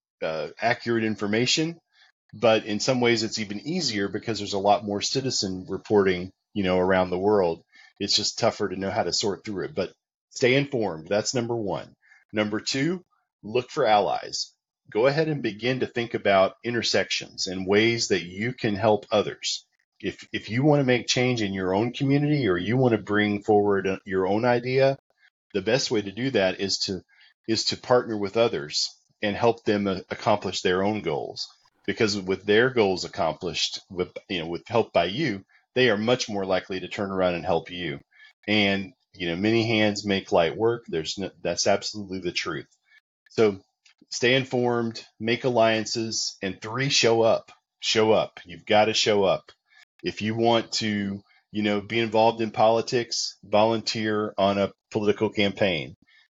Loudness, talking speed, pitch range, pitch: -25 LUFS, 175 wpm, 100-120 Hz, 110 Hz